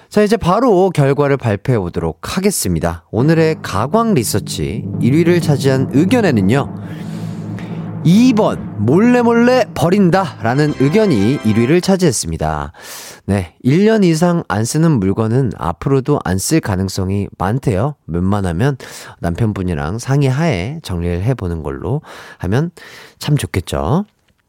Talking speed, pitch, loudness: 265 characters per minute, 135 Hz, -15 LUFS